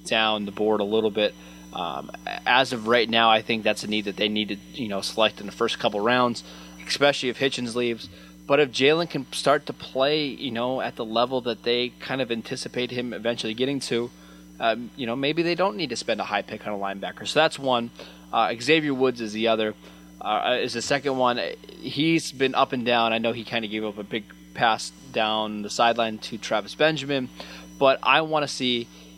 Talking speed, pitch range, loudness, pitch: 220 wpm, 105-130 Hz, -24 LUFS, 115 Hz